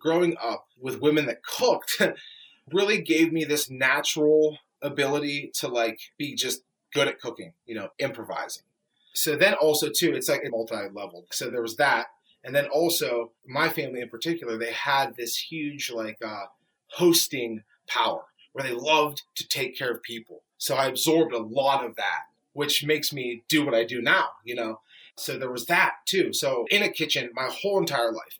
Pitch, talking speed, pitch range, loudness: 145 Hz, 185 wpm, 120-160 Hz, -25 LUFS